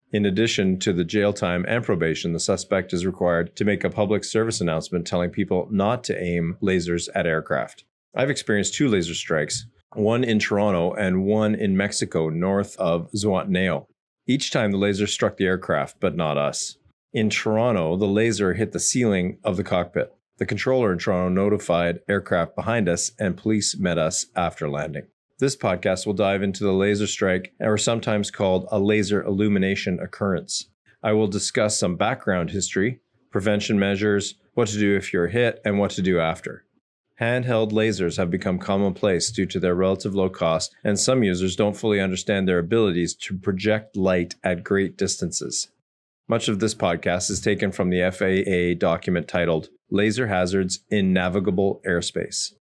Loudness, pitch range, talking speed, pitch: -23 LUFS, 90-105 Hz, 170 wpm, 100 Hz